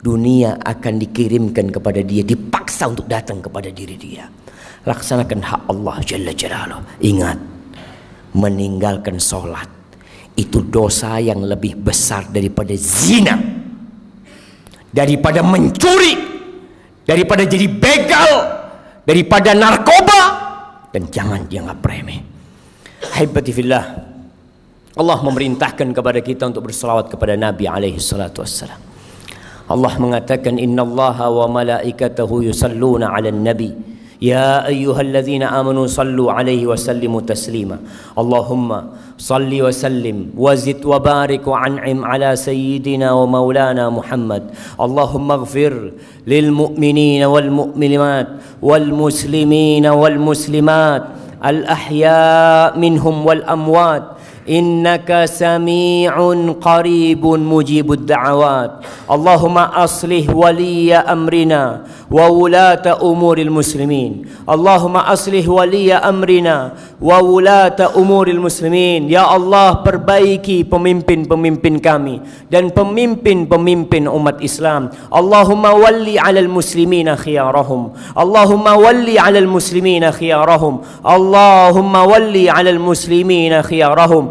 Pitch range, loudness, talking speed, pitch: 125-175 Hz, -12 LUFS, 100 wpm, 150 Hz